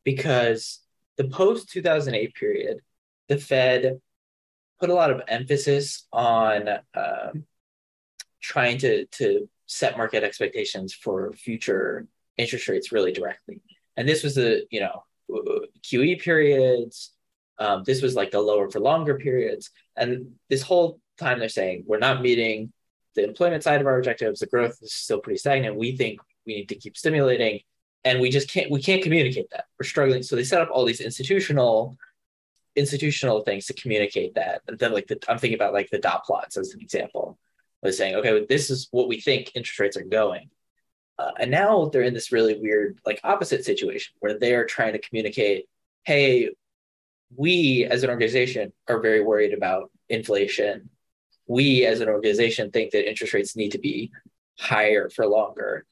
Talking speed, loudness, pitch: 170 wpm, -23 LUFS, 140 Hz